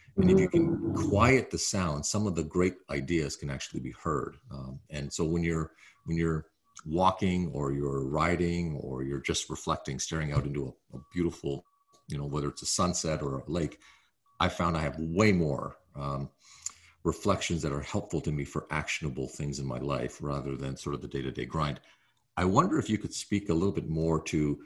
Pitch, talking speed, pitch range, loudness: 80 Hz, 200 wpm, 70-85 Hz, -31 LUFS